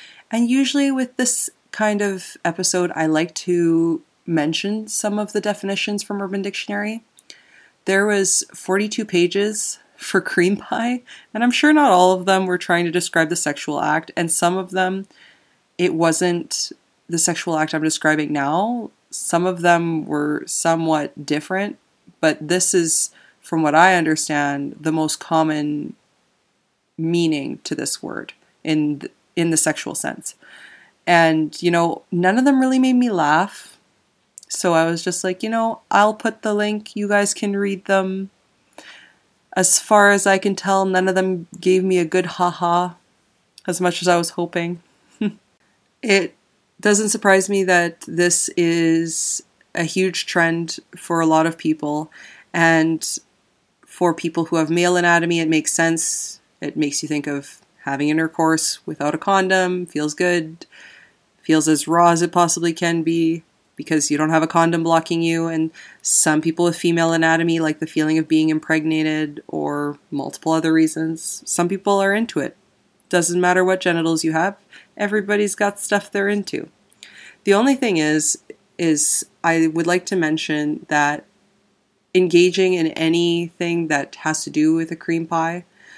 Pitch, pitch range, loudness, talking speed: 175 Hz, 160-195 Hz, -19 LUFS, 160 wpm